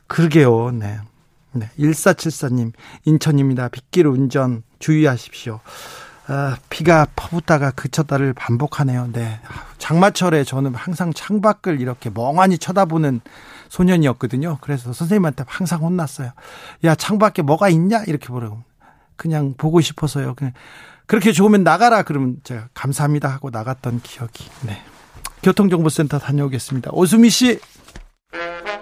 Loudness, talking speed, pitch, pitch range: -18 LUFS, 310 characters per minute, 145 Hz, 130-170 Hz